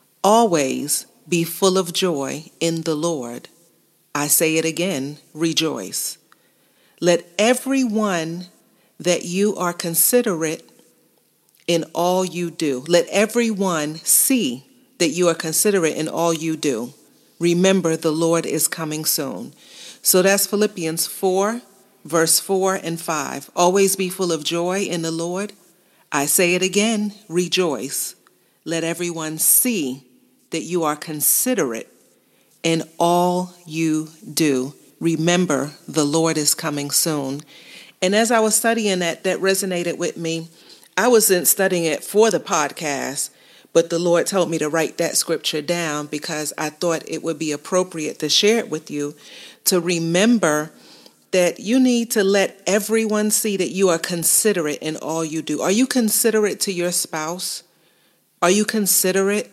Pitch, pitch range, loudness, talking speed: 175 Hz, 160-195 Hz, -19 LUFS, 145 wpm